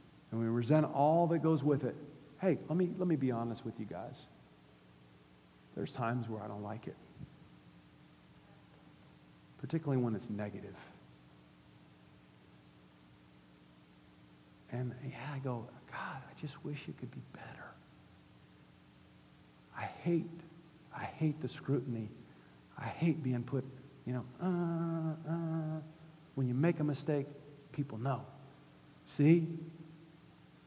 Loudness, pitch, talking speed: -37 LUFS, 130 Hz, 125 wpm